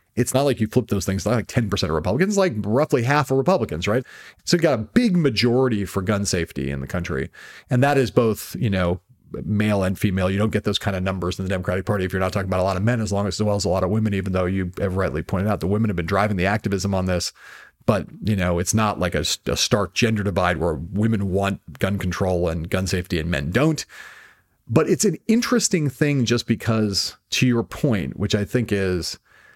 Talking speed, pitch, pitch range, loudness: 245 wpm, 100 Hz, 95-120 Hz, -22 LUFS